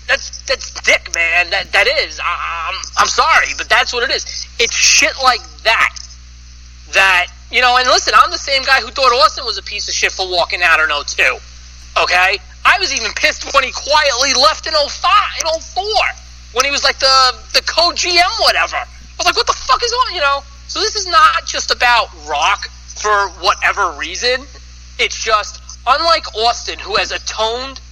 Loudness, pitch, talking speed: -13 LUFS, 265 Hz, 195 wpm